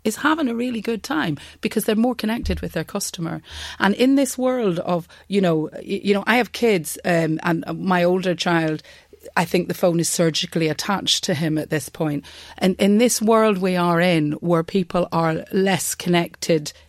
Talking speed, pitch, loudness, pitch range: 190 wpm, 180 Hz, -21 LUFS, 165-220 Hz